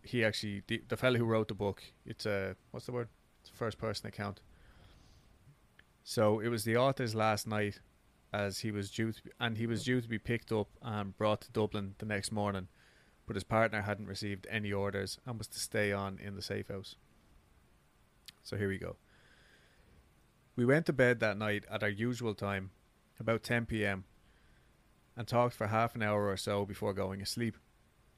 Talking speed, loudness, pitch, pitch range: 195 wpm, -35 LUFS, 105 Hz, 100-115 Hz